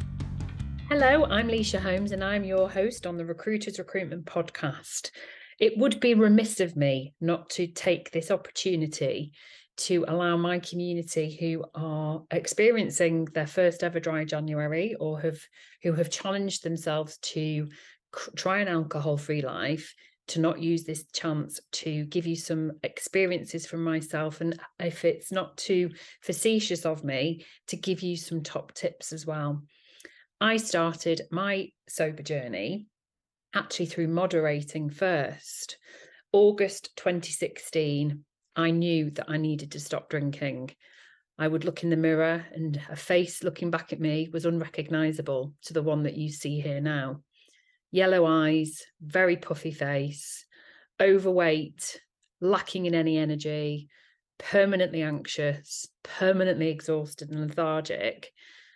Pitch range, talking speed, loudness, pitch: 155-185 Hz, 135 wpm, -28 LUFS, 165 Hz